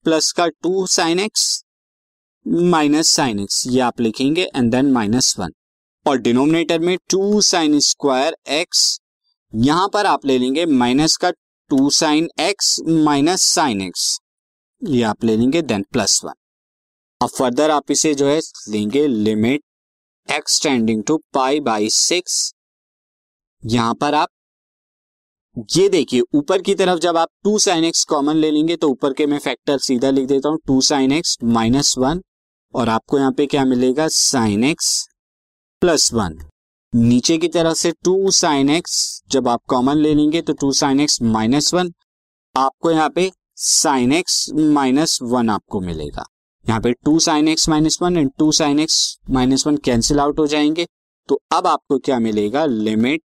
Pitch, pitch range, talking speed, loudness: 145 Hz, 120-160 Hz, 165 wpm, -16 LUFS